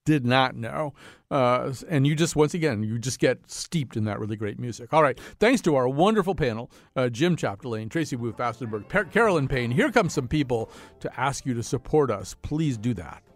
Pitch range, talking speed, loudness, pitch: 115-155 Hz, 205 wpm, -25 LUFS, 135 Hz